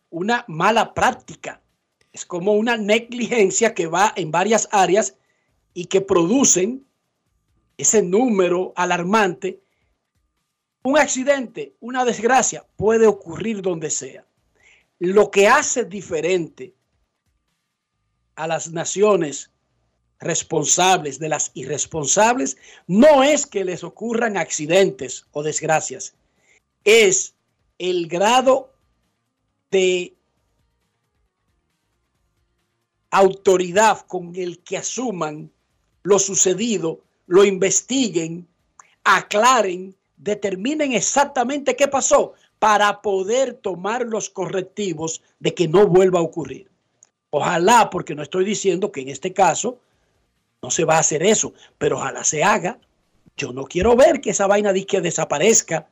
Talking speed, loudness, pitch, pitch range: 110 wpm, -18 LUFS, 190 Hz, 165-220 Hz